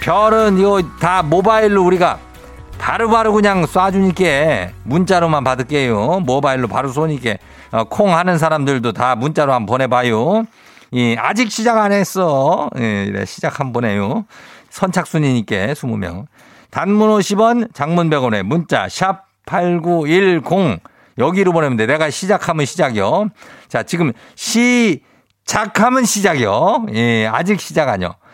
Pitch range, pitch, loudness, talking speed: 130-200 Hz, 170 Hz, -15 LUFS, 270 characters per minute